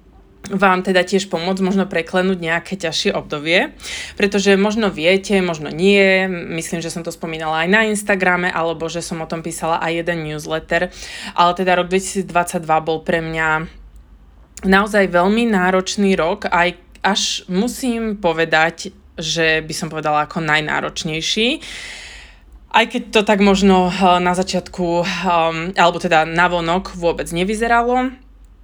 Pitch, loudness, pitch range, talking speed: 180 Hz, -17 LUFS, 165-195 Hz, 135 wpm